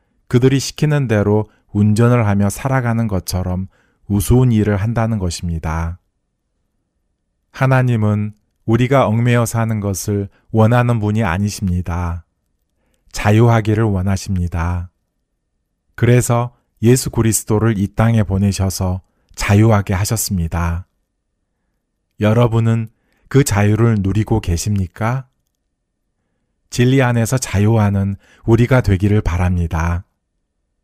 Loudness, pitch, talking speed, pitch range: -16 LUFS, 105 Hz, 245 characters per minute, 90-115 Hz